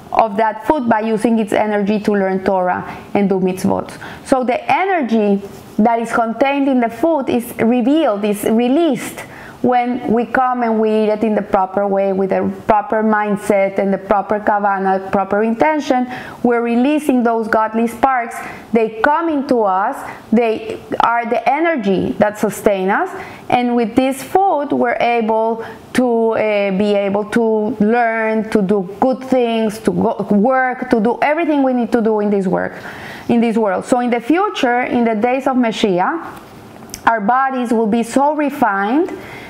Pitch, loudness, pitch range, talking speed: 230 Hz, -16 LUFS, 210-255 Hz, 165 wpm